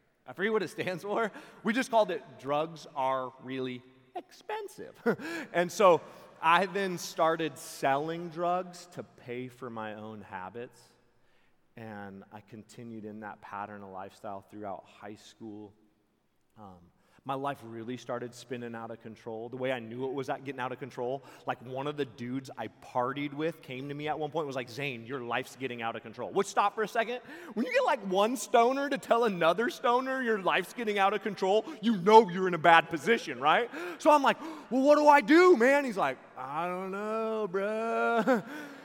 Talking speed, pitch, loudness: 195 wpm, 150 Hz, -29 LUFS